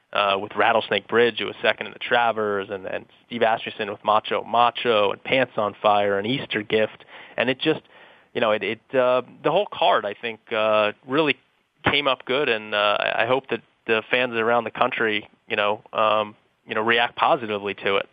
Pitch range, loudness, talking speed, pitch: 105-125 Hz, -22 LUFS, 200 wpm, 110 Hz